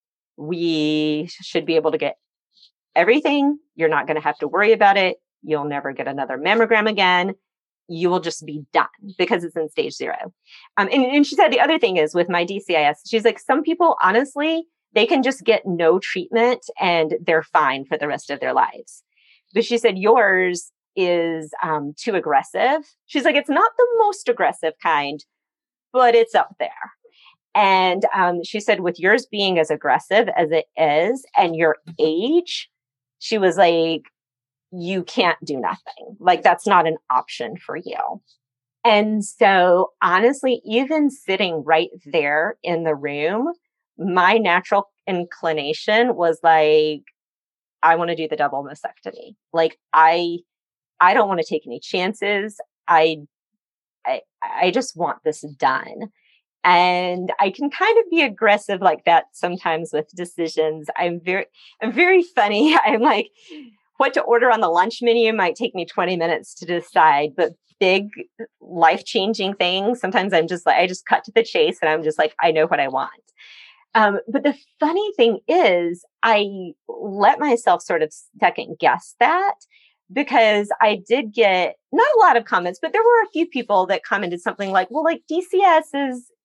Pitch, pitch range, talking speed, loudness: 190 Hz, 160-245 Hz, 170 wpm, -19 LUFS